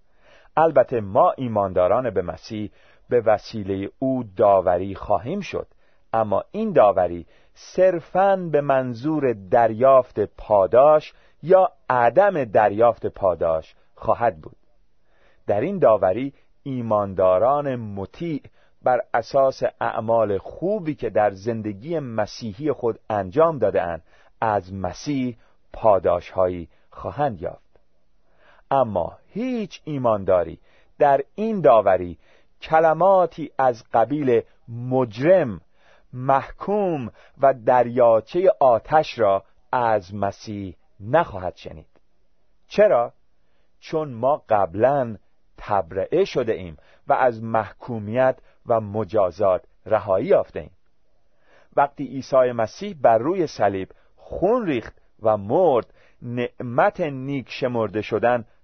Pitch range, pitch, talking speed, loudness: 105-150 Hz, 125 Hz, 95 wpm, -21 LUFS